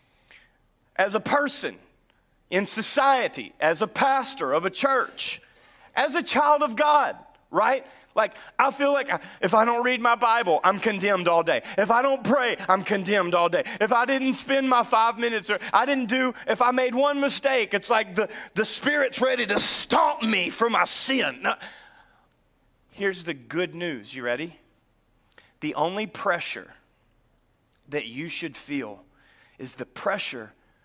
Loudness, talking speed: -23 LUFS, 165 wpm